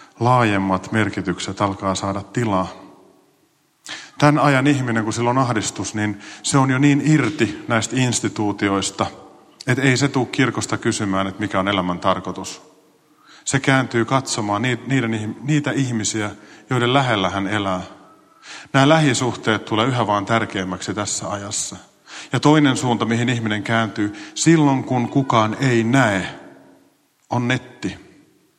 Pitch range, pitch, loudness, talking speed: 100-130 Hz, 115 Hz, -19 LUFS, 130 wpm